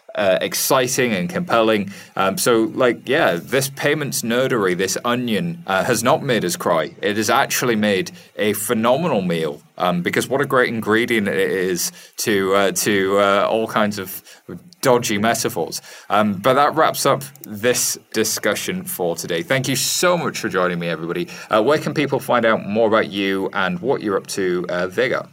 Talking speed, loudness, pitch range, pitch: 180 wpm, -19 LUFS, 100-135 Hz, 115 Hz